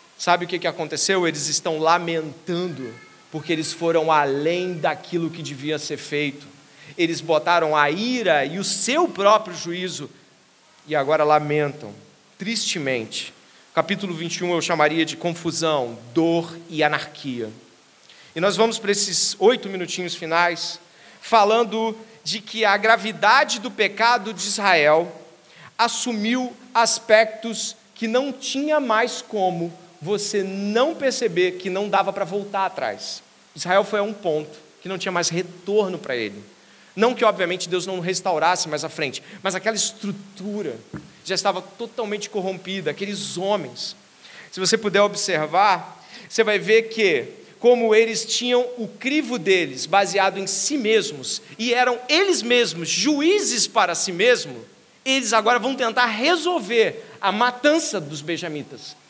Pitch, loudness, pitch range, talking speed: 195 Hz, -21 LUFS, 165-225 Hz, 140 wpm